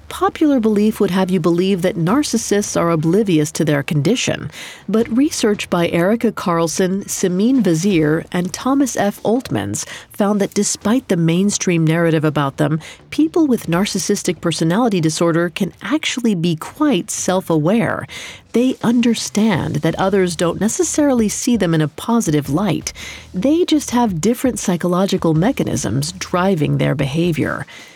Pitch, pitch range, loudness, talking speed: 190 Hz, 170-230 Hz, -17 LUFS, 135 wpm